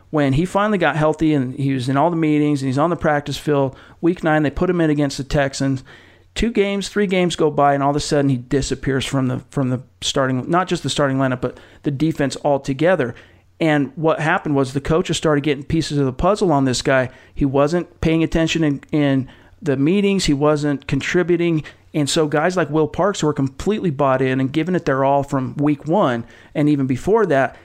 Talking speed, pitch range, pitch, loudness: 220 wpm, 135-160 Hz, 145 Hz, -19 LUFS